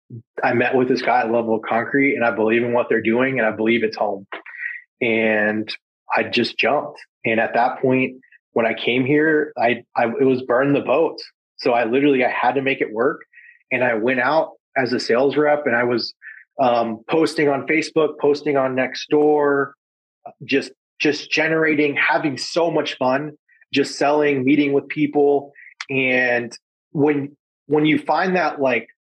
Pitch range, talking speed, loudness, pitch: 120-150 Hz, 175 wpm, -19 LUFS, 140 Hz